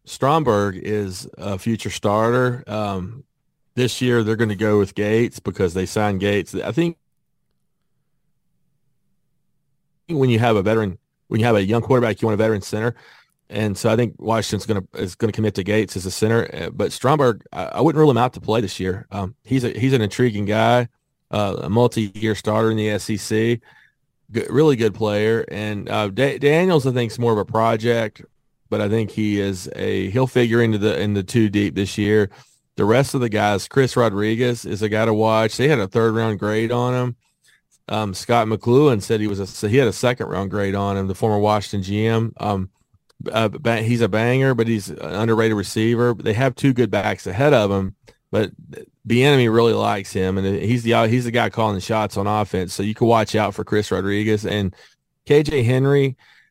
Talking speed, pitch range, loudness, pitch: 205 wpm, 105-120 Hz, -20 LUFS, 110 Hz